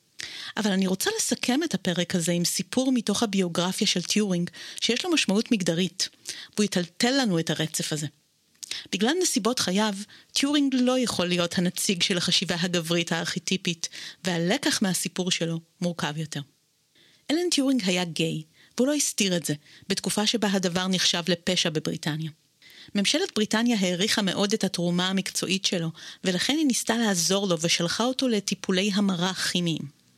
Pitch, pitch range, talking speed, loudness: 185 Hz, 175-215 Hz, 145 wpm, -25 LUFS